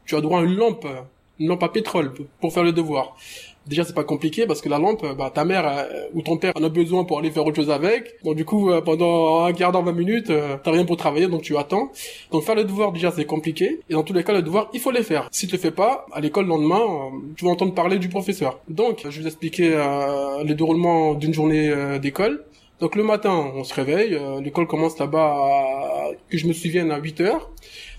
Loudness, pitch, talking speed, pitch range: -21 LUFS, 165 Hz, 260 wpm, 150-185 Hz